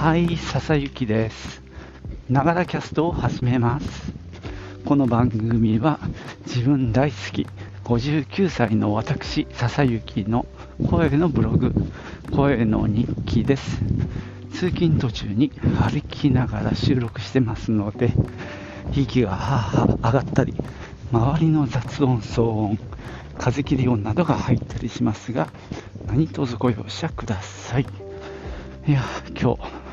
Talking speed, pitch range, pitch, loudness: 220 characters per minute, 105-140 Hz, 120 Hz, -22 LUFS